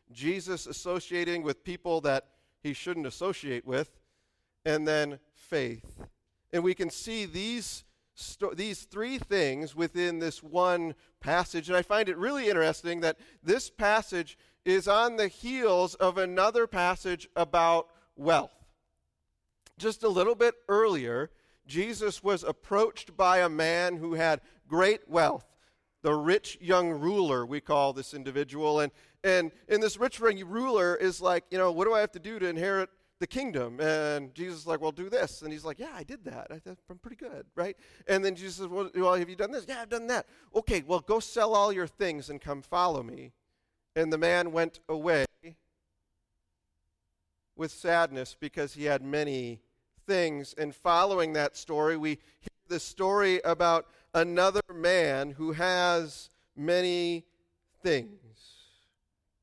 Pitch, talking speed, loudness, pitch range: 175 Hz, 155 wpm, -29 LUFS, 150-190 Hz